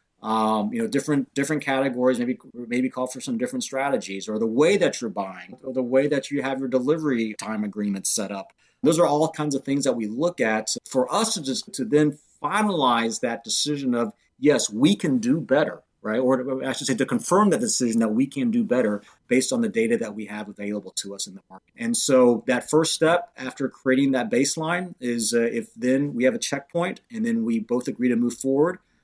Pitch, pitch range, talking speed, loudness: 135 Hz, 120-175 Hz, 225 wpm, -23 LUFS